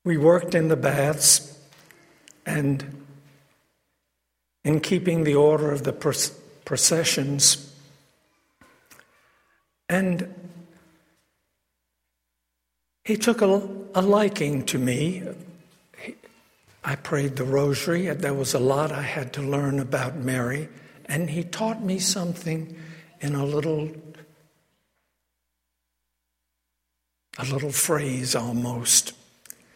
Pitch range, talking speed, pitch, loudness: 130-170 Hz, 100 wpm, 145 Hz, -23 LUFS